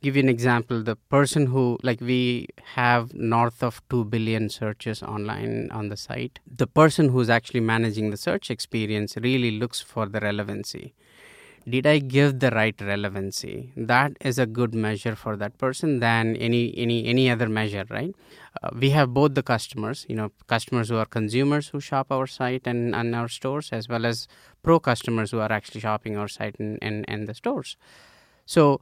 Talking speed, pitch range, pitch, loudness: 190 wpm, 110-130 Hz, 120 Hz, -24 LUFS